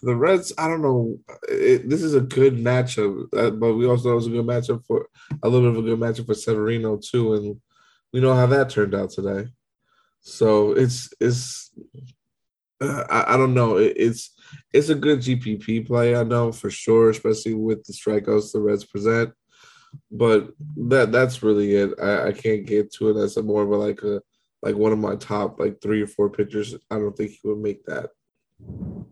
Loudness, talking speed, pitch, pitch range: -21 LUFS, 205 wpm, 115 Hz, 105-125 Hz